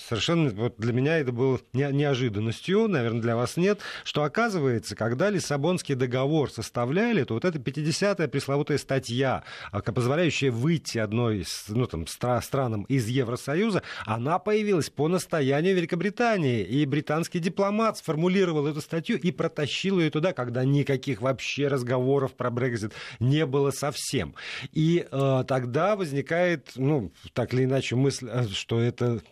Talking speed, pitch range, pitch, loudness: 135 wpm, 125-165 Hz, 140 Hz, -26 LUFS